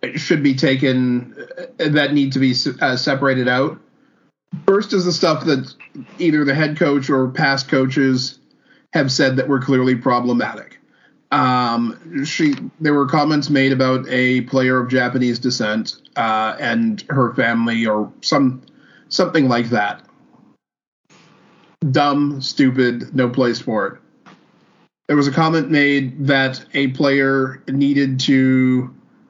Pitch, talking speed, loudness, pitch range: 135 Hz, 135 wpm, -17 LUFS, 130-150 Hz